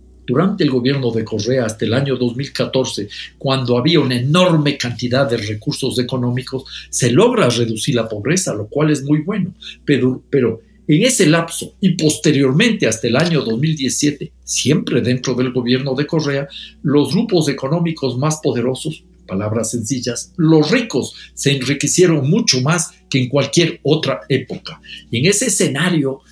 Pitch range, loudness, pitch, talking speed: 125-160 Hz, -16 LUFS, 140 Hz, 150 wpm